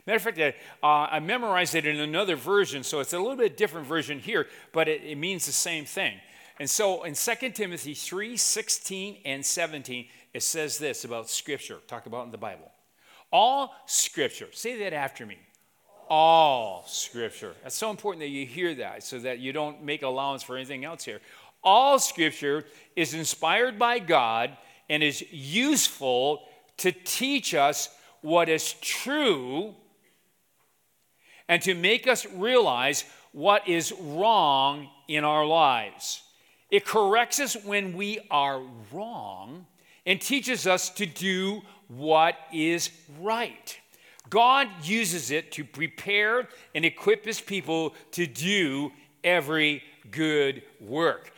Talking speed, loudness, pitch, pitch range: 145 wpm, -26 LUFS, 170 Hz, 150-210 Hz